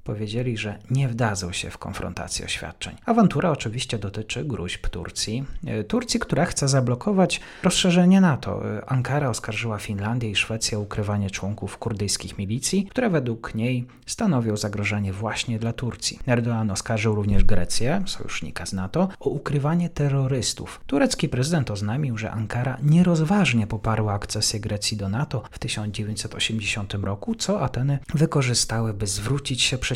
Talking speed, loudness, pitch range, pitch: 135 wpm, -24 LUFS, 105-140 Hz, 115 Hz